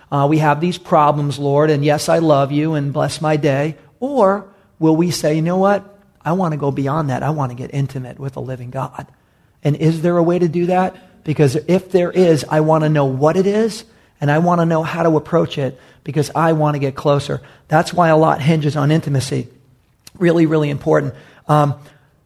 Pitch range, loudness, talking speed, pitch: 145-170 Hz, -16 LUFS, 220 wpm, 155 Hz